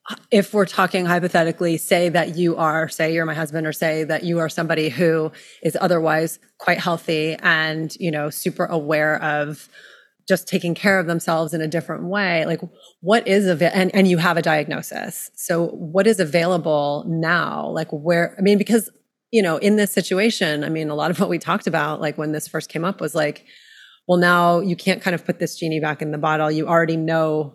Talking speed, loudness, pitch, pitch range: 210 wpm, -20 LUFS, 170 Hz, 160-185 Hz